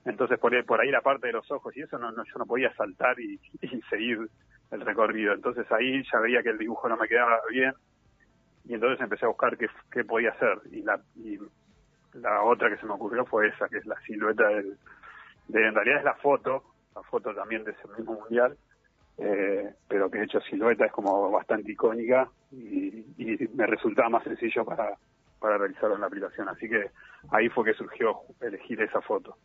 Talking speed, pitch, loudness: 210 wpm, 290 Hz, -27 LUFS